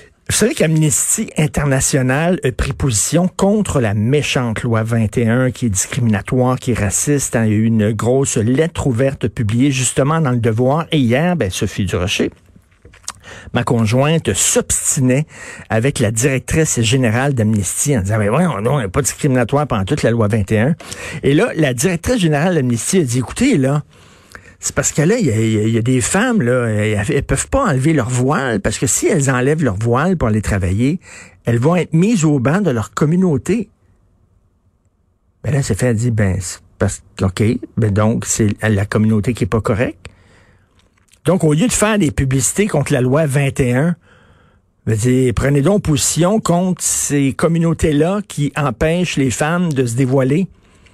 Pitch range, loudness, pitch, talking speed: 110-150 Hz, -15 LUFS, 125 Hz, 175 wpm